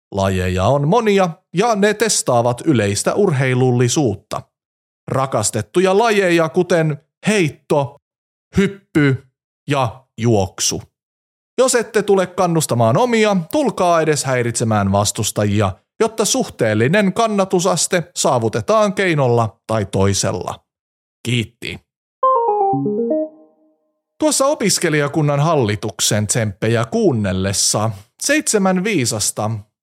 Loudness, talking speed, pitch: -17 LUFS, 80 wpm, 150 Hz